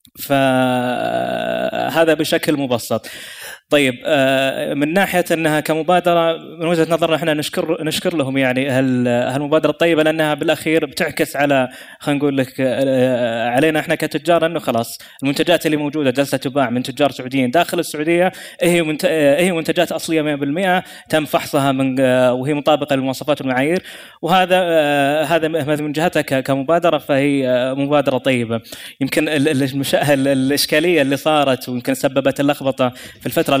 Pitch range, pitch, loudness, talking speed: 135-160 Hz, 150 Hz, -17 LUFS, 125 wpm